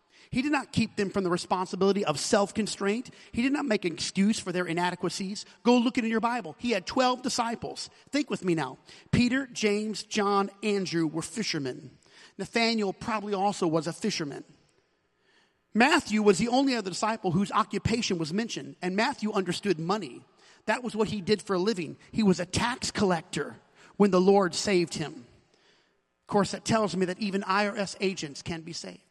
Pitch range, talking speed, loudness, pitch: 180-220 Hz, 185 wpm, -28 LUFS, 200 Hz